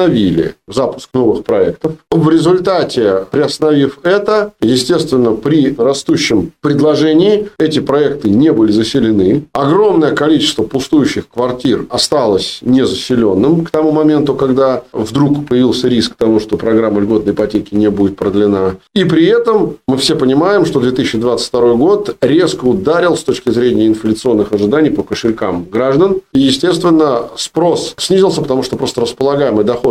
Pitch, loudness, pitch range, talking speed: 135 Hz, -12 LUFS, 115-160 Hz, 130 wpm